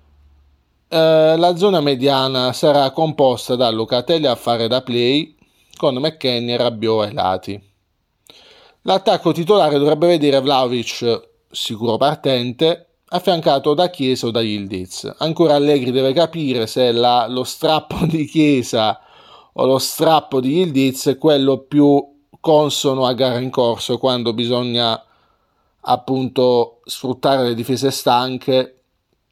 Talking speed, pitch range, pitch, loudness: 125 wpm, 120-150 Hz, 130 Hz, -17 LUFS